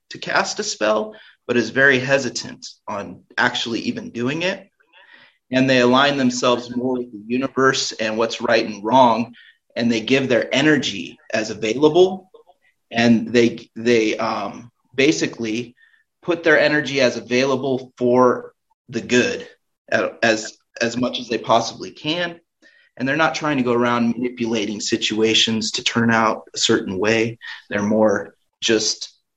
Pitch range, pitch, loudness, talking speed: 115-135 Hz, 120 Hz, -19 LUFS, 145 wpm